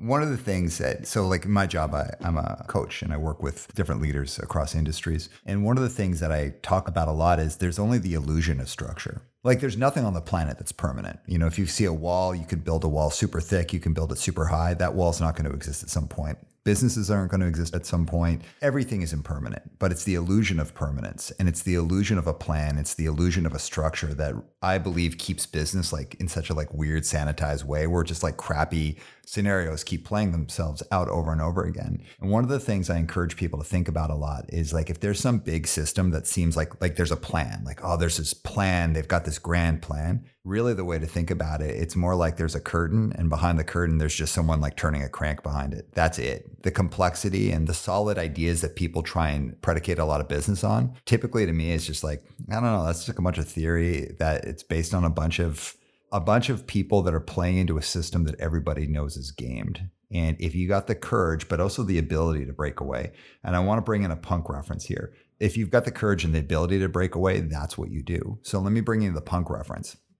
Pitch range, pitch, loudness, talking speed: 80-95 Hz, 85 Hz, -26 LUFS, 255 wpm